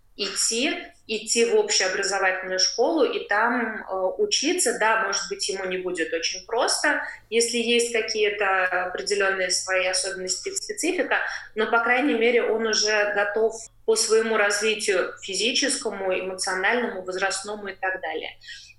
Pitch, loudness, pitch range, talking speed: 210 Hz, -23 LUFS, 190-235 Hz, 130 wpm